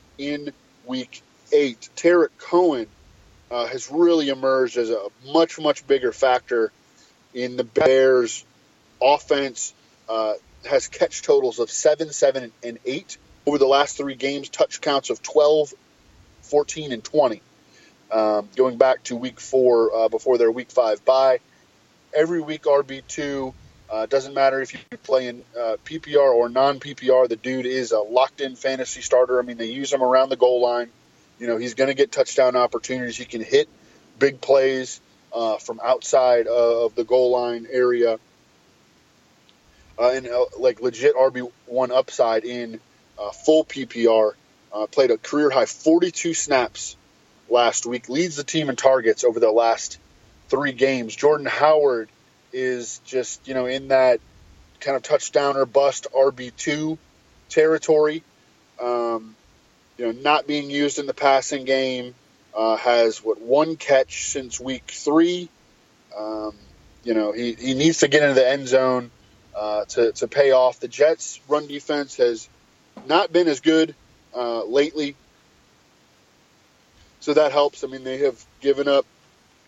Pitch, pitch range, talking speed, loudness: 130 Hz, 120-150 Hz, 150 wpm, -21 LUFS